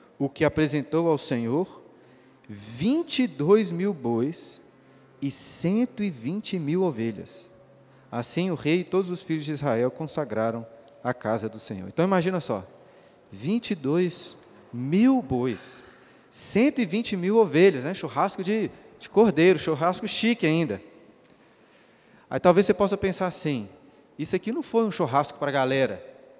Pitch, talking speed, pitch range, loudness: 160 Hz, 130 wpm, 130-195 Hz, -25 LUFS